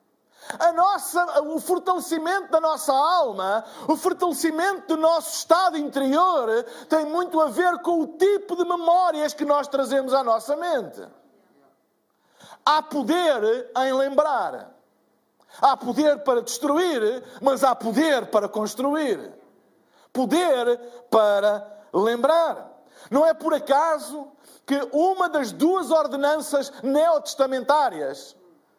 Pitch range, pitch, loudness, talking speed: 270-335 Hz, 300 Hz, -22 LUFS, 115 wpm